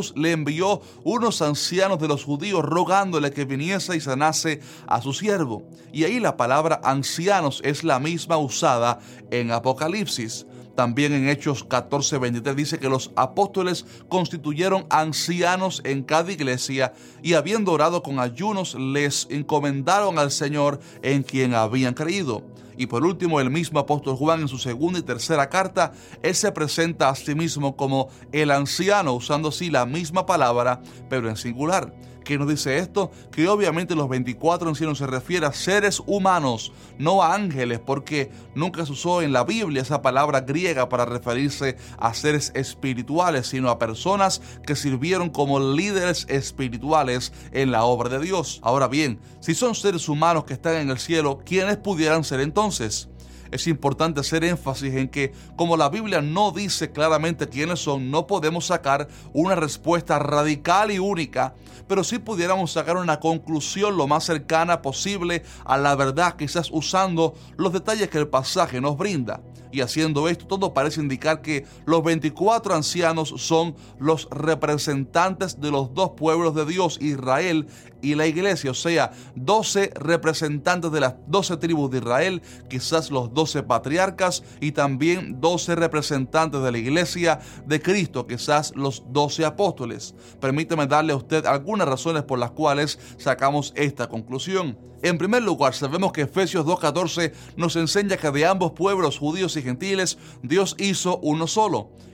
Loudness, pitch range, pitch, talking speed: -23 LUFS, 135-170 Hz, 150 Hz, 160 wpm